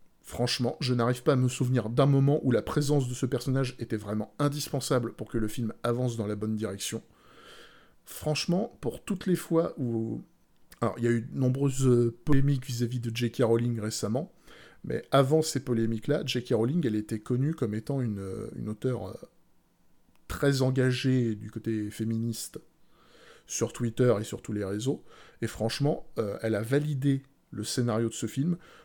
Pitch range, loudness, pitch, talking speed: 115-140 Hz, -29 LUFS, 120 Hz, 170 wpm